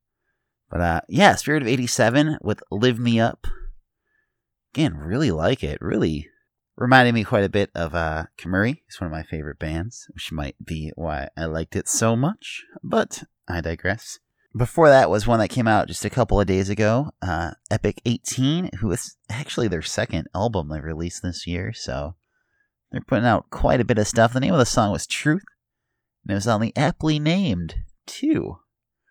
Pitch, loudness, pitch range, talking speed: 105 Hz, -22 LUFS, 85-125 Hz, 185 wpm